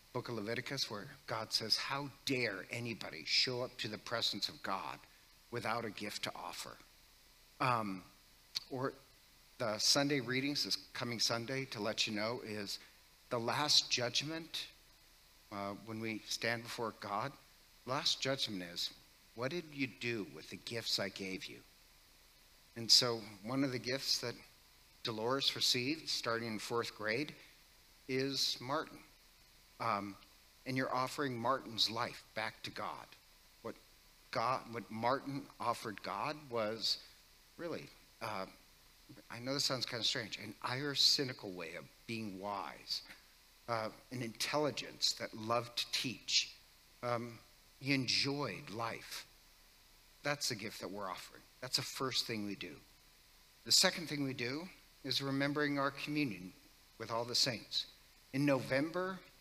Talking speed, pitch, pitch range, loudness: 140 wpm, 120 Hz, 110-135 Hz, -37 LUFS